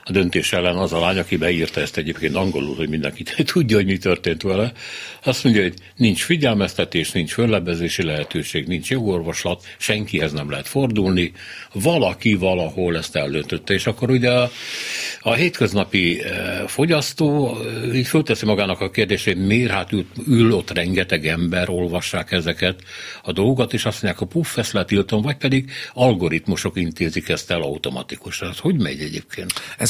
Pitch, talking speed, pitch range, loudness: 100 Hz, 155 wpm, 90-120 Hz, -20 LUFS